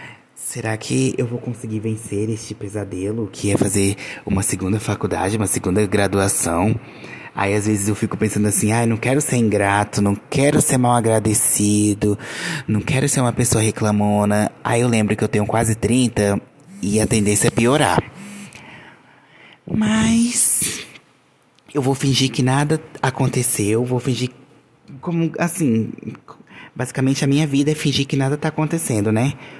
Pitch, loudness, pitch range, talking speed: 115 Hz, -18 LUFS, 105-140 Hz, 155 wpm